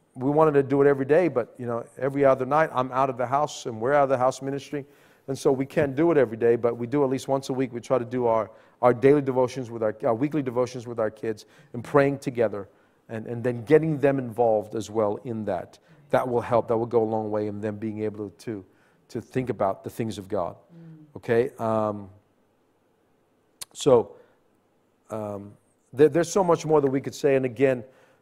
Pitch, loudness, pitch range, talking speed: 130 Hz, -24 LUFS, 115-140 Hz, 225 wpm